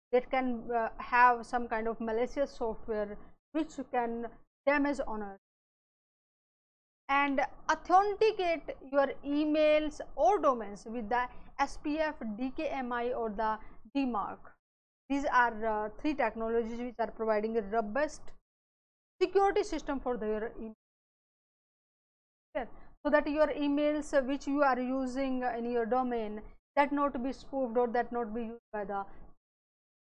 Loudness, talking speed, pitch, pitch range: -32 LUFS, 130 wpm, 250 Hz, 230-285 Hz